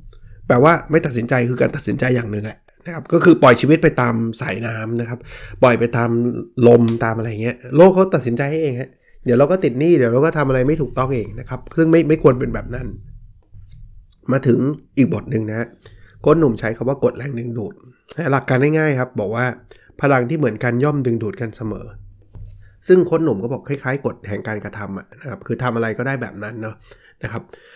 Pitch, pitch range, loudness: 120 Hz, 110-140 Hz, -17 LUFS